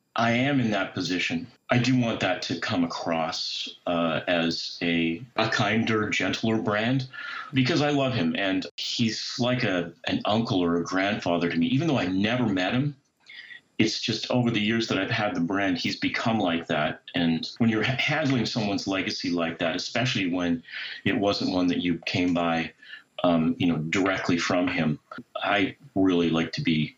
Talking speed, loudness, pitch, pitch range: 180 wpm, -26 LUFS, 105 Hz, 85-125 Hz